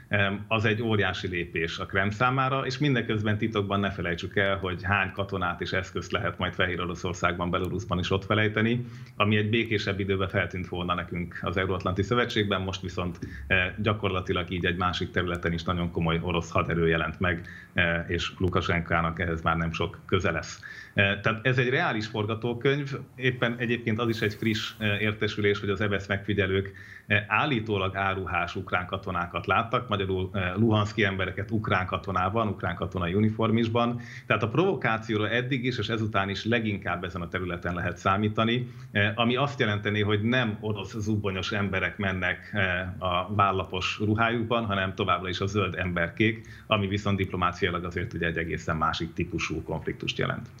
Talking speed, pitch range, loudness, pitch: 160 wpm, 90-110 Hz, -27 LUFS, 100 Hz